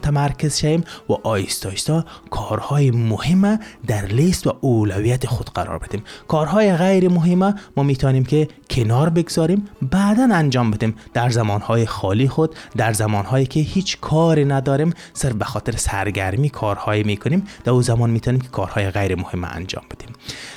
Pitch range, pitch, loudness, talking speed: 110-160 Hz, 125 Hz, -19 LUFS, 150 wpm